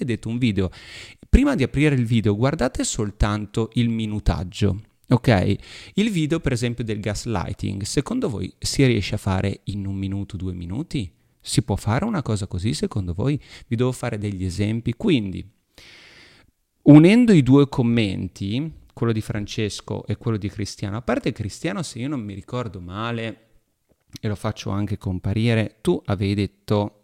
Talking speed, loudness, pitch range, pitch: 160 wpm, -22 LUFS, 100-125 Hz, 110 Hz